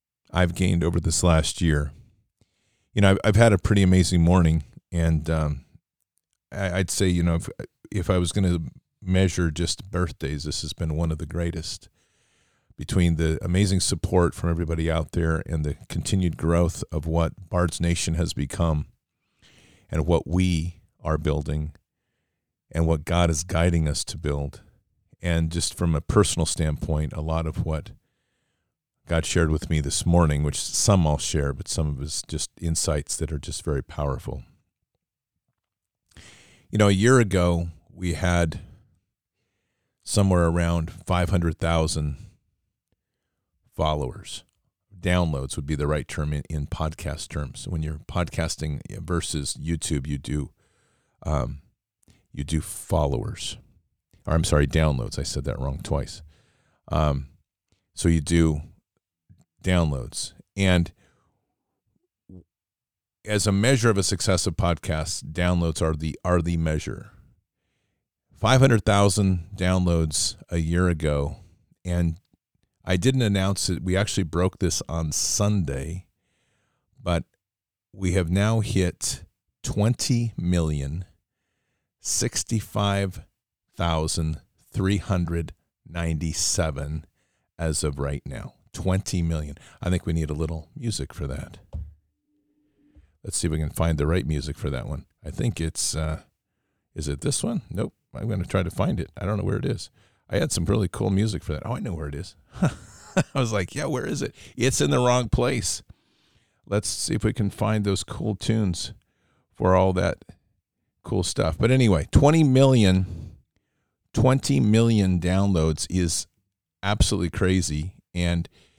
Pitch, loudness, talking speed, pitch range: 85 Hz, -24 LUFS, 150 wpm, 80-100 Hz